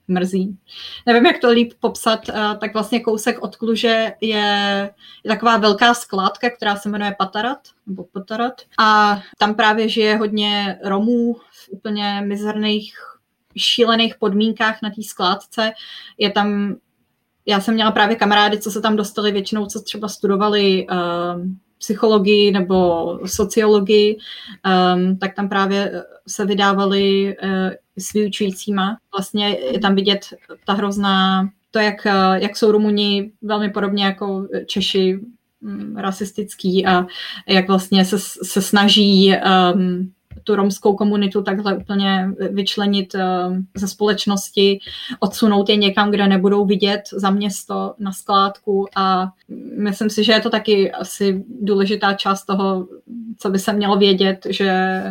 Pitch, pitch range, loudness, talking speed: 205 Hz, 195-215 Hz, -17 LUFS, 130 wpm